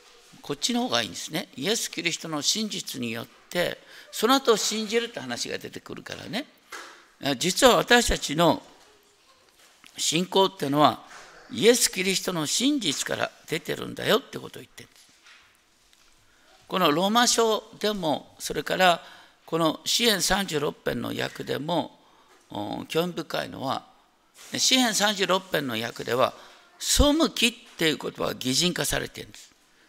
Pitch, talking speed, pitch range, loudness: 200 Hz, 275 characters per minute, 165-235 Hz, -25 LUFS